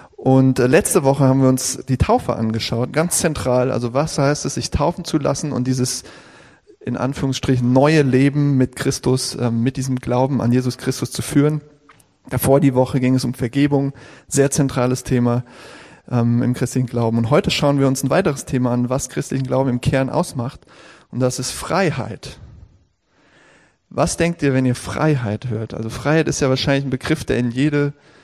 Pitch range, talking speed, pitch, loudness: 125-140 Hz, 180 wpm, 130 Hz, -18 LUFS